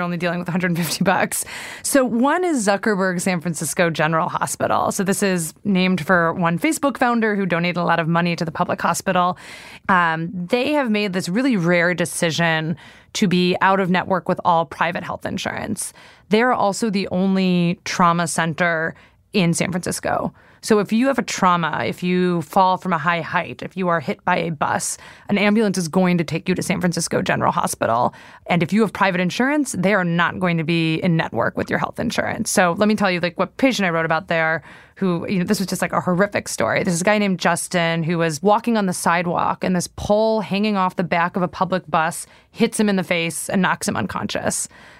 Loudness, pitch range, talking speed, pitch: -20 LUFS, 170-200 Hz, 215 wpm, 180 Hz